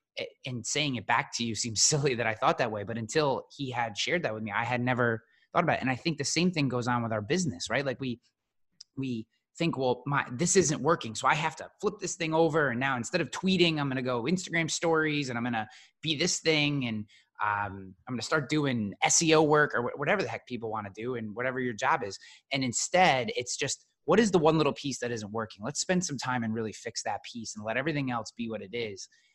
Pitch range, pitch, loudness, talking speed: 115-160 Hz, 130 Hz, -29 LUFS, 255 wpm